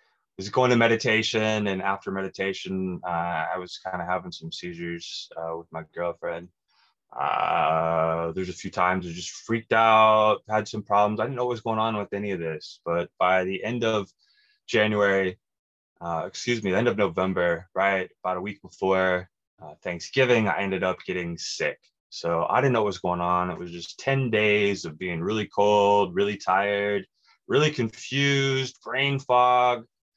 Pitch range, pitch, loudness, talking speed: 90-115 Hz, 100 Hz, -25 LUFS, 175 wpm